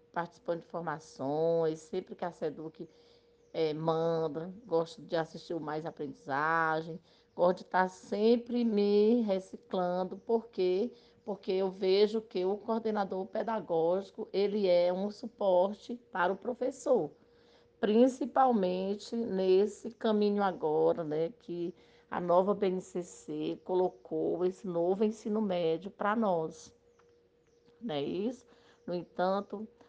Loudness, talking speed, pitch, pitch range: -32 LUFS, 115 wpm, 190 Hz, 170-220 Hz